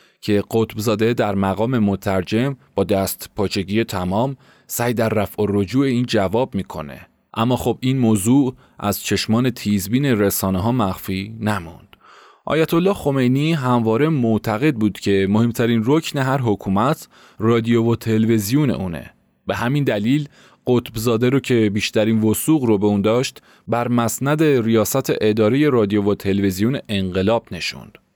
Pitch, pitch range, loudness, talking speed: 115 Hz, 105-130 Hz, -19 LUFS, 135 wpm